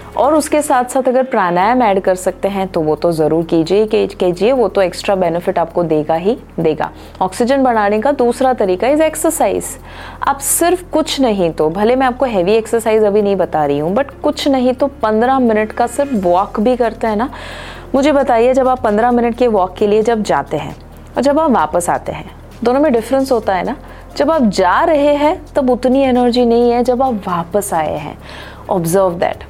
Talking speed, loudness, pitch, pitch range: 210 wpm, -14 LUFS, 225 Hz, 190-260 Hz